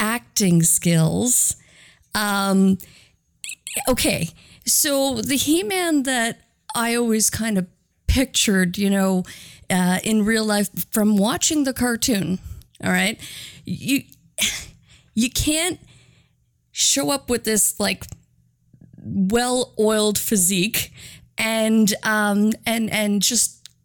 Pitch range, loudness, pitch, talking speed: 195-245 Hz, -20 LUFS, 220 Hz, 100 wpm